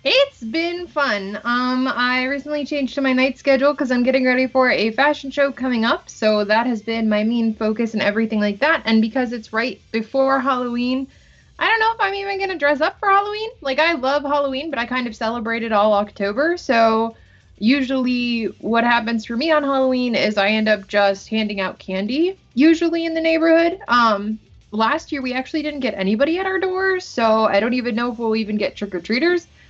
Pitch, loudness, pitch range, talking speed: 255 Hz, -19 LUFS, 225-290 Hz, 210 wpm